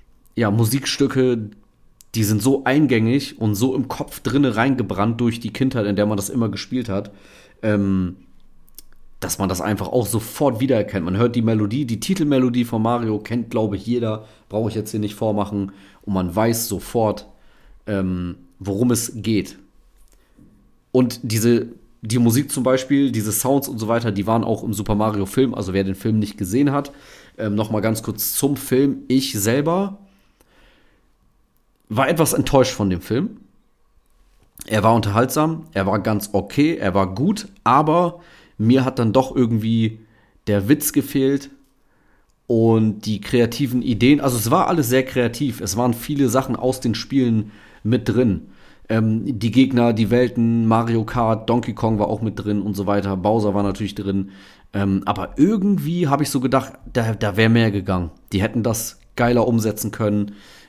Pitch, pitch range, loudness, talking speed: 115 Hz, 105-130 Hz, -20 LUFS, 170 wpm